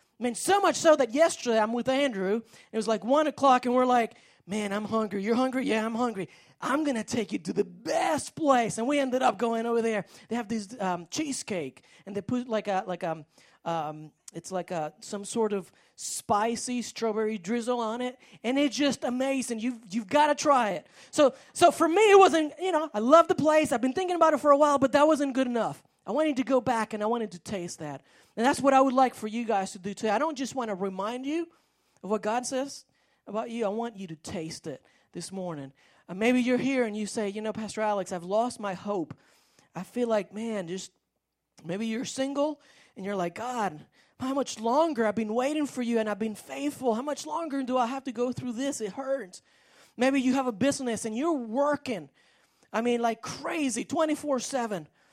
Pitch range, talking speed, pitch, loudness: 210-275 Hz, 230 wpm, 240 Hz, -28 LUFS